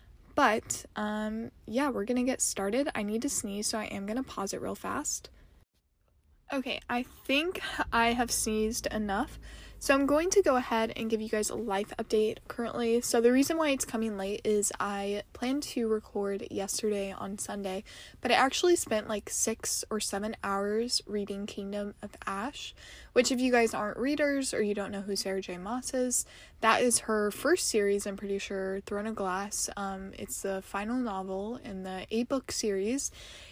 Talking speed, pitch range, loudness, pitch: 185 wpm, 200-250 Hz, -31 LUFS, 220 Hz